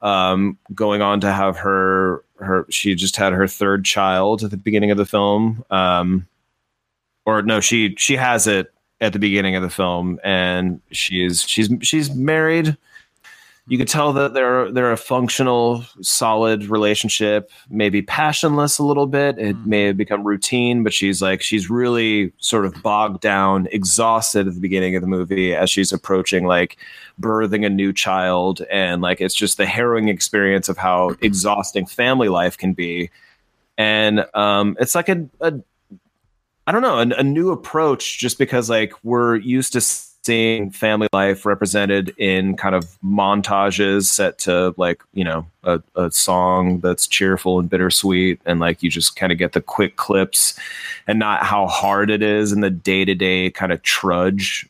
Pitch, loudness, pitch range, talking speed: 100 Hz, -18 LUFS, 95-110 Hz, 175 wpm